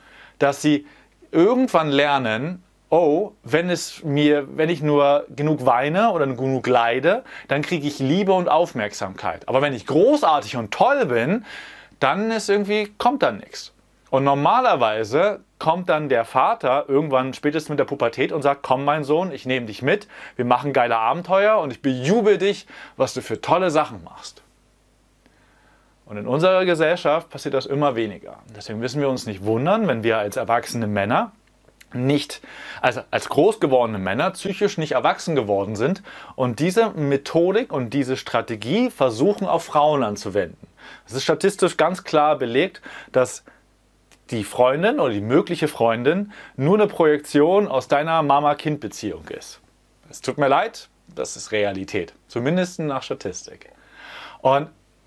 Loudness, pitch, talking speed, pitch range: -21 LUFS, 145 Hz, 155 wpm, 125-175 Hz